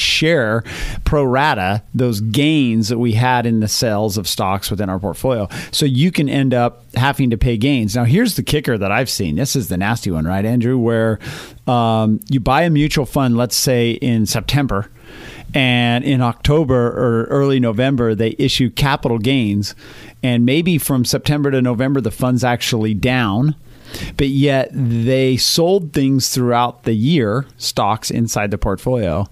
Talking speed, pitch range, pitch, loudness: 170 wpm, 115-135 Hz, 125 Hz, -16 LUFS